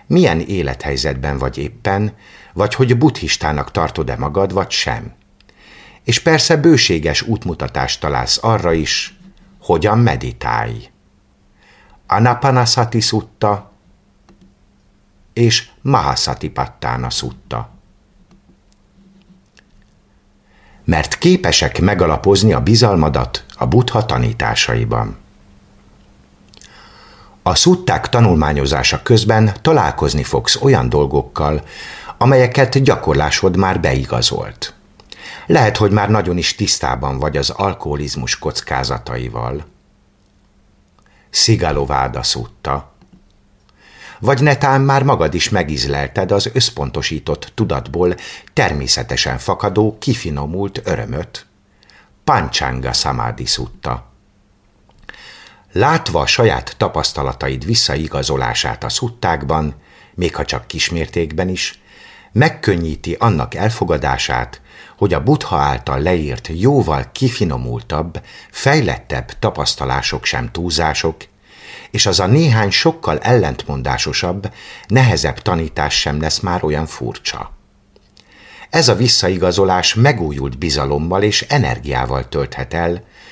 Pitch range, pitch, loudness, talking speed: 70-115 Hz, 95 Hz, -15 LUFS, 90 wpm